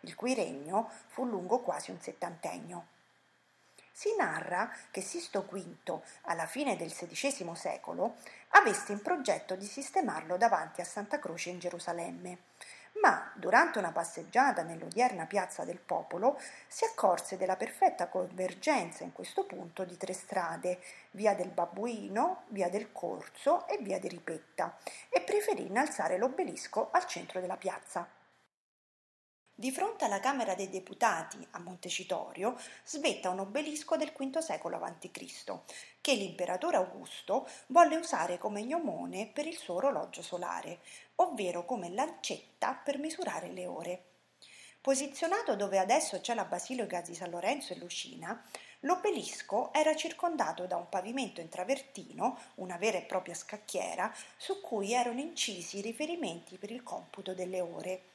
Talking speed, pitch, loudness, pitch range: 140 wpm, 215 Hz, -34 LUFS, 185-295 Hz